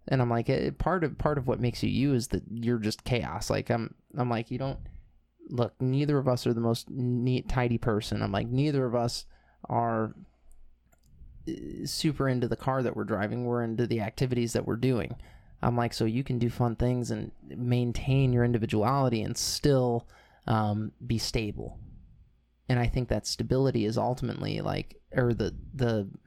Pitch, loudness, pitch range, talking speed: 120 Hz, -29 LUFS, 110-125 Hz, 185 wpm